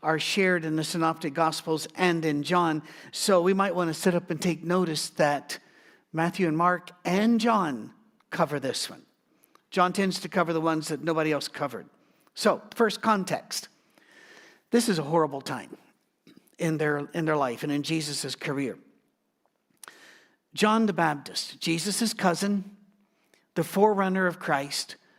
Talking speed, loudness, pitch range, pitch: 150 wpm, -27 LUFS, 155-195 Hz, 170 Hz